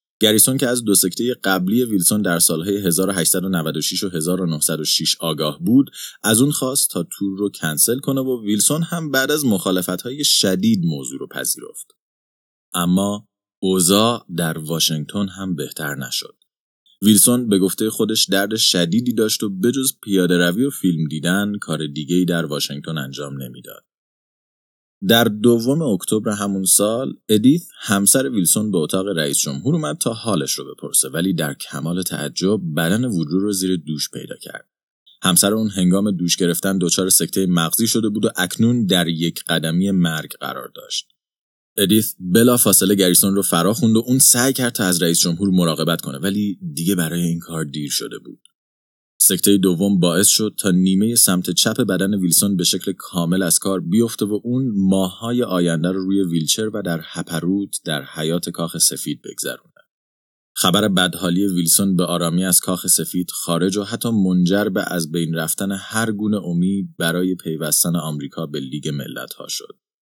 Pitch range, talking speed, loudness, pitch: 85-105 Hz, 165 wpm, -18 LUFS, 95 Hz